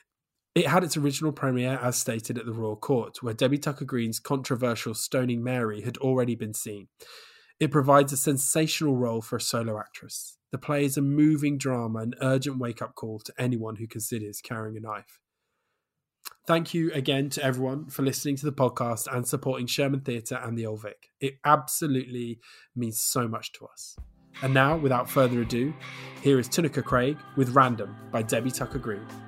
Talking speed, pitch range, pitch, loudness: 180 wpm, 115-140 Hz, 130 Hz, -27 LUFS